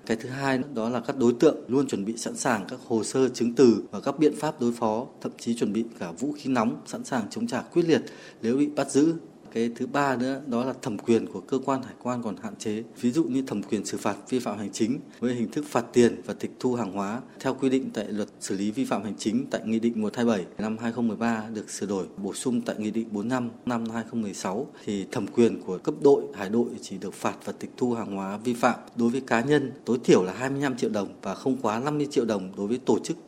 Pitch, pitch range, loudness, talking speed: 120 Hz, 115-135 Hz, -27 LUFS, 260 wpm